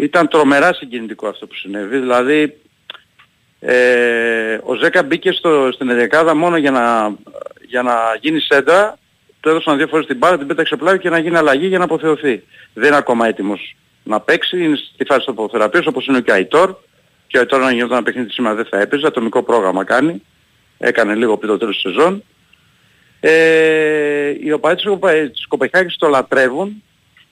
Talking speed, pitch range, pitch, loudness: 180 wpm, 125-165 Hz, 150 Hz, -14 LUFS